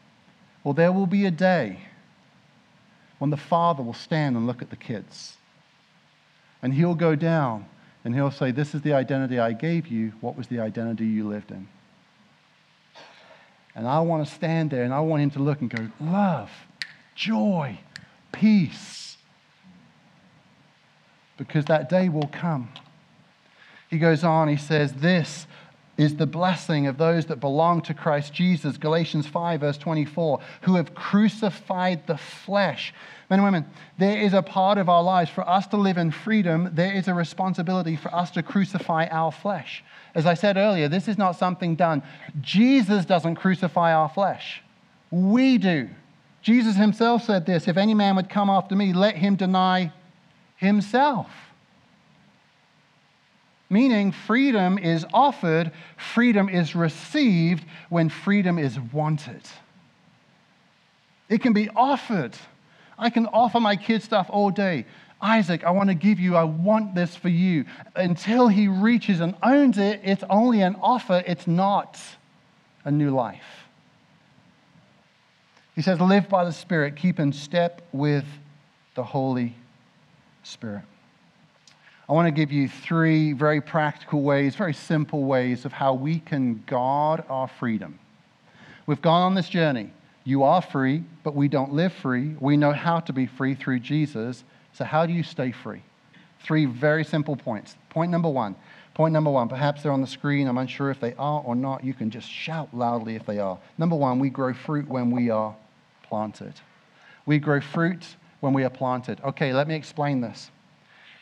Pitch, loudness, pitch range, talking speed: 165 Hz, -23 LUFS, 145-185 Hz, 160 wpm